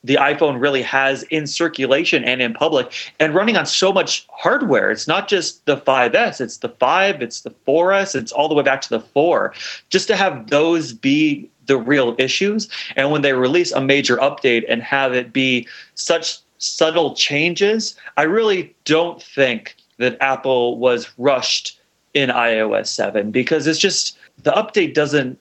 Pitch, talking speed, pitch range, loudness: 145 Hz, 170 wpm, 130-175 Hz, -17 LUFS